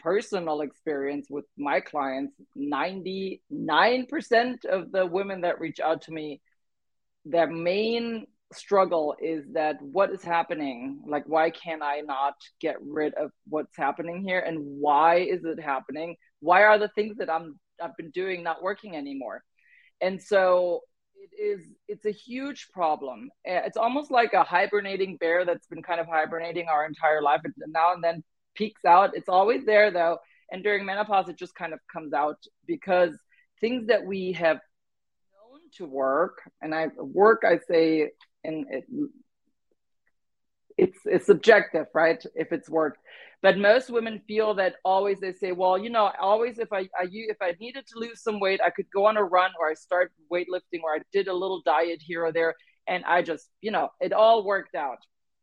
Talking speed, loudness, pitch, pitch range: 175 wpm, -26 LUFS, 185 Hz, 160-215 Hz